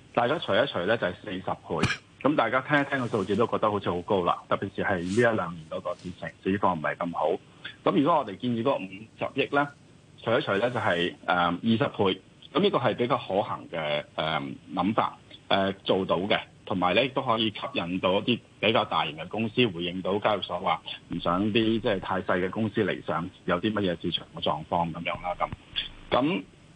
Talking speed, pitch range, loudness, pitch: 300 characters per minute, 90-115 Hz, -27 LUFS, 100 Hz